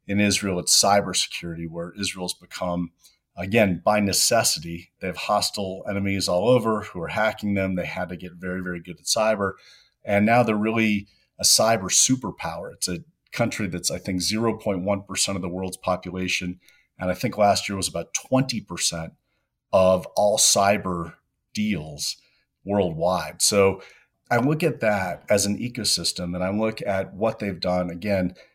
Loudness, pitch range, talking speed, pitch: -23 LUFS, 90-105 Hz, 160 wpm, 95 Hz